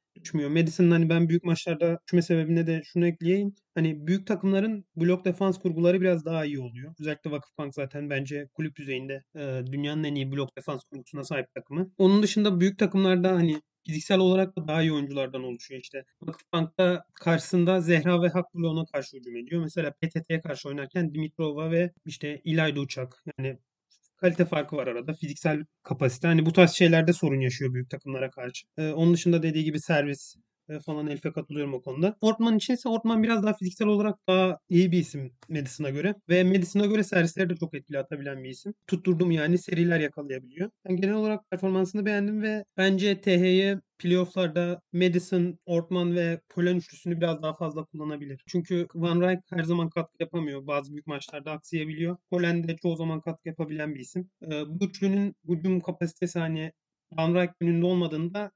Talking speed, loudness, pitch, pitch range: 170 wpm, -27 LUFS, 170 Hz, 150-180 Hz